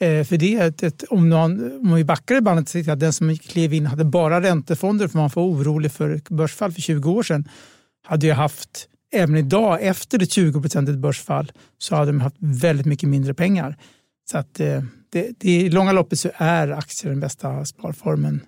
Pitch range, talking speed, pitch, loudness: 150-175 Hz, 200 wpm, 160 Hz, -20 LUFS